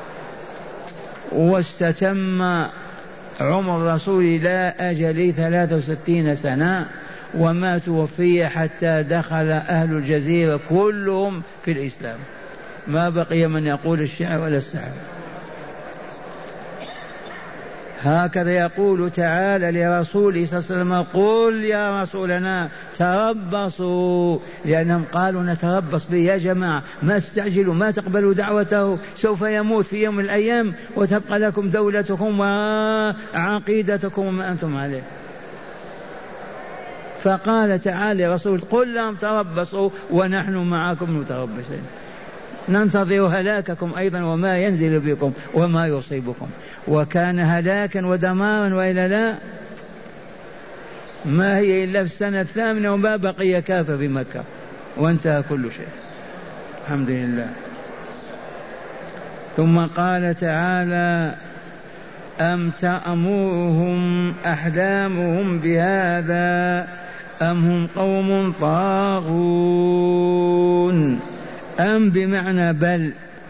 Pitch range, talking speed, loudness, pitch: 165-195 Hz, 90 wpm, -20 LUFS, 180 Hz